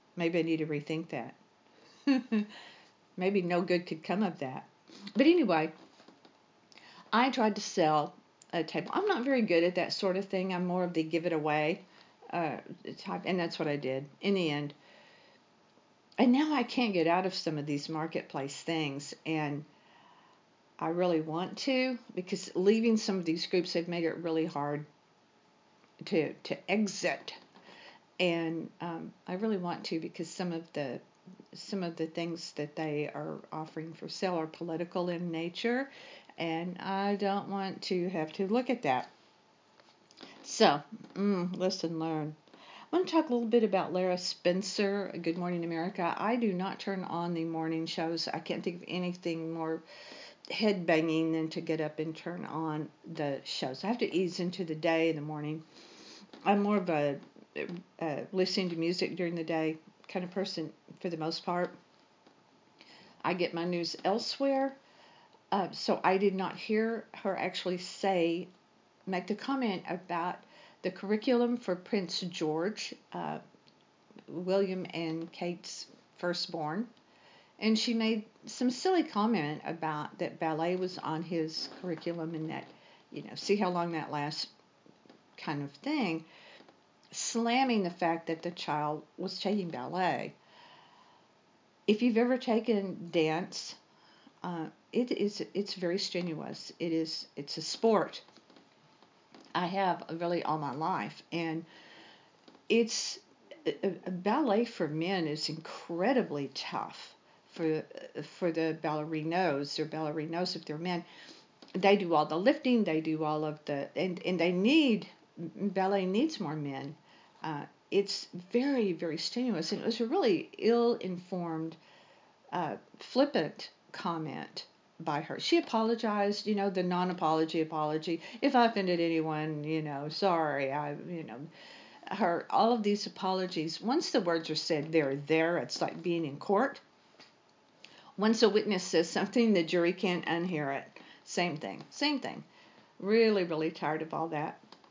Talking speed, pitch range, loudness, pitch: 155 wpm, 160-205 Hz, -33 LUFS, 175 Hz